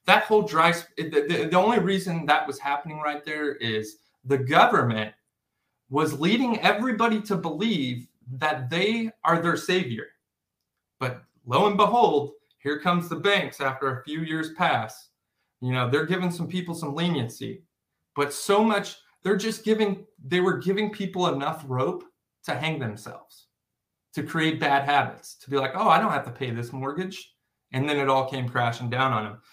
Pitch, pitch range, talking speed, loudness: 155 Hz, 135-185 Hz, 175 wpm, -25 LUFS